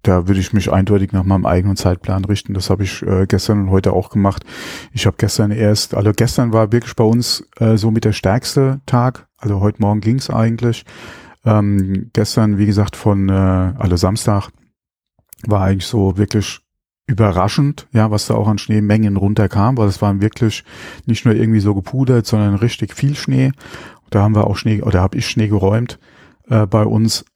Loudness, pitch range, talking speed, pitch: -16 LUFS, 100-115 Hz, 195 wpm, 105 Hz